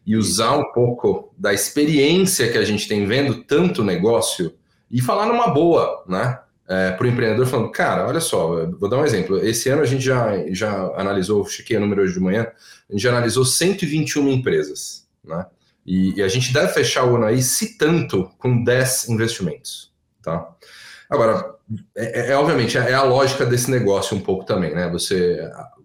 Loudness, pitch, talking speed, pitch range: -19 LUFS, 120 Hz, 185 wpm, 105-135 Hz